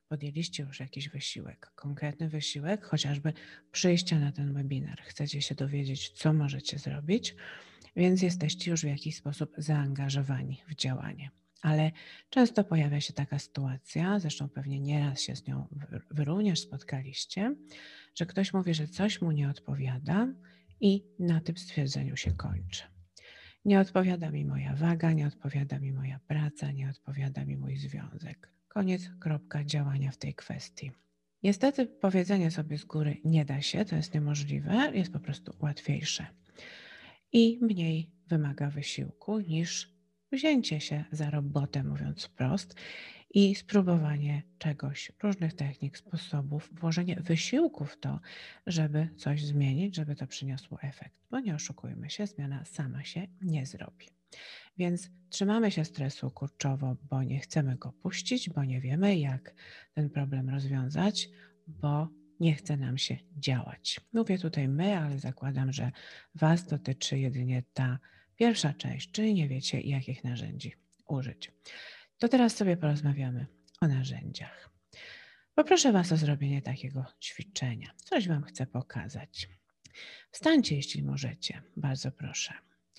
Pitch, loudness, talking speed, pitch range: 150 Hz, -32 LUFS, 135 wpm, 135-175 Hz